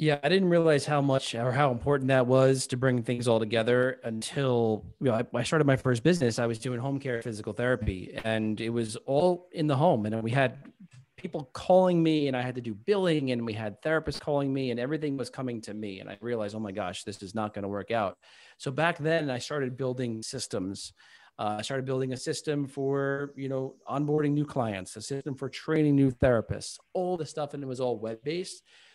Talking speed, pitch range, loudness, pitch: 225 wpm, 115-145 Hz, -29 LUFS, 130 Hz